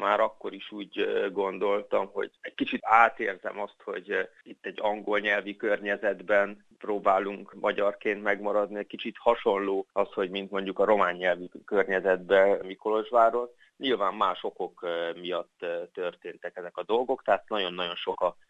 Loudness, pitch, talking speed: -28 LUFS, 105 Hz, 140 wpm